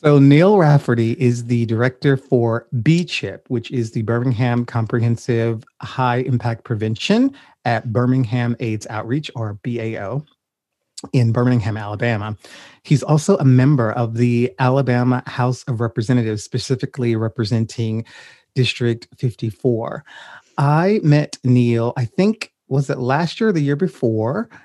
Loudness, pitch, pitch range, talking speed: -18 LUFS, 125 Hz, 115-140 Hz, 125 wpm